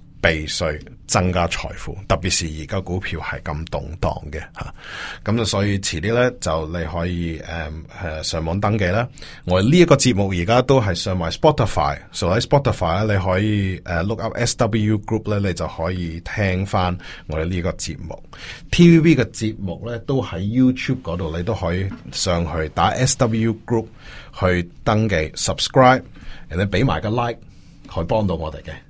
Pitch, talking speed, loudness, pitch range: 95 Hz, 345 characters per minute, -20 LUFS, 85-115 Hz